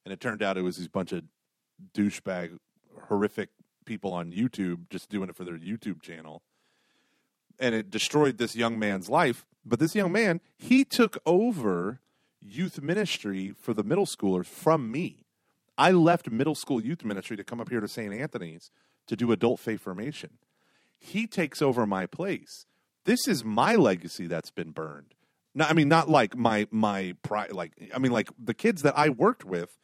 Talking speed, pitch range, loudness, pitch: 185 wpm, 95-160 Hz, -28 LUFS, 115 Hz